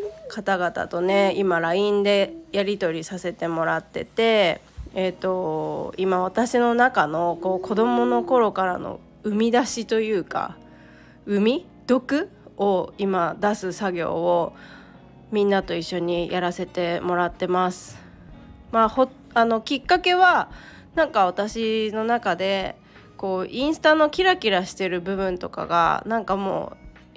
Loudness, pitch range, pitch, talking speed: -23 LUFS, 180-225 Hz, 195 Hz, 255 characters per minute